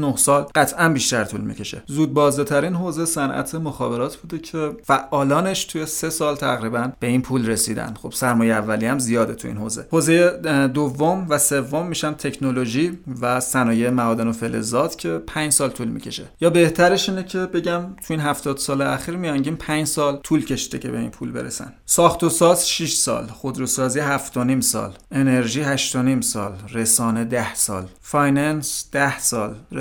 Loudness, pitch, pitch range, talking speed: -20 LUFS, 140 Hz, 125-155 Hz, 175 wpm